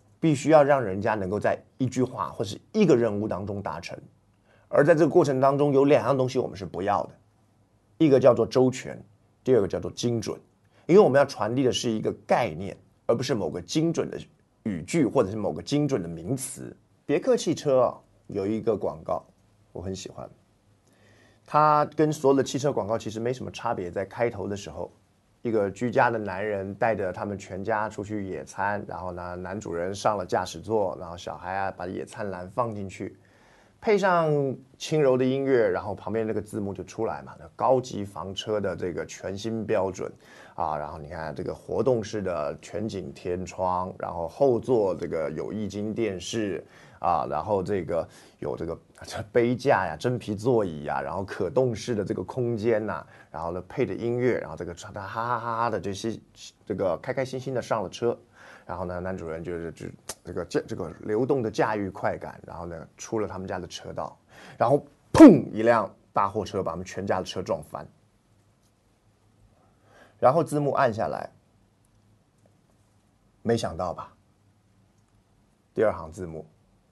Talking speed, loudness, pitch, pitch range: 270 characters per minute, -26 LUFS, 105 Hz, 95-120 Hz